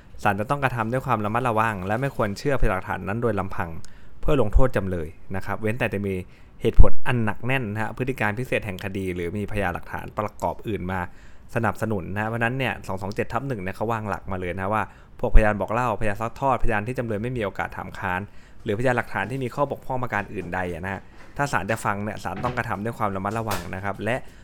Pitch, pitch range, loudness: 105 Hz, 95-115 Hz, -26 LUFS